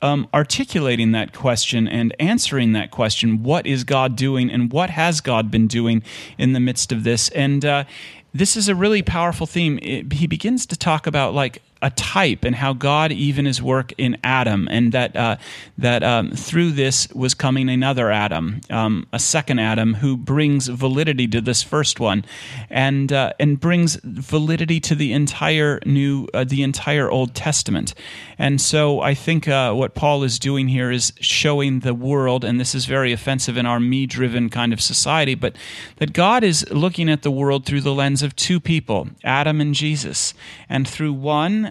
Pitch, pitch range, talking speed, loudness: 135 Hz, 125-150 Hz, 185 wpm, -19 LUFS